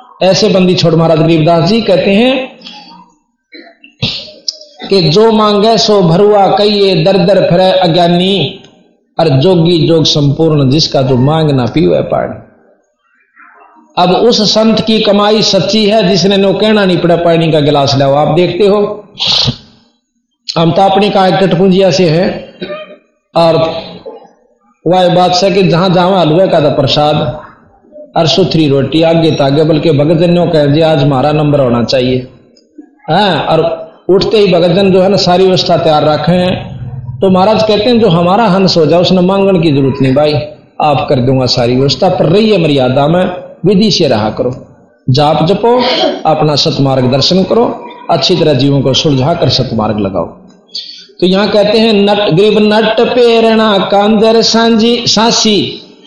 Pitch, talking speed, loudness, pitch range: 180 Hz, 150 wpm, -8 LUFS, 155-205 Hz